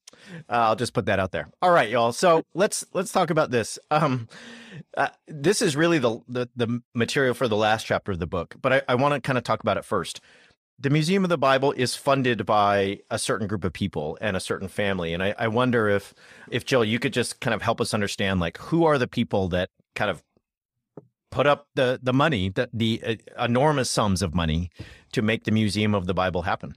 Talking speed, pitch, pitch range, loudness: 230 wpm, 120 Hz, 105-140 Hz, -24 LUFS